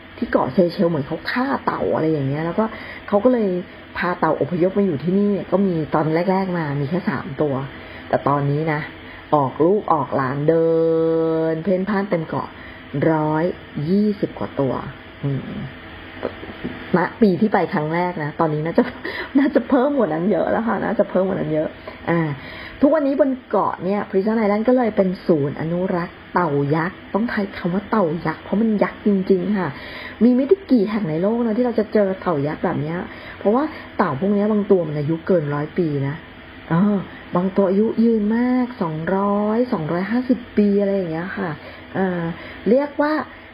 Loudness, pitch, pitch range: -20 LUFS, 190 Hz, 160-210 Hz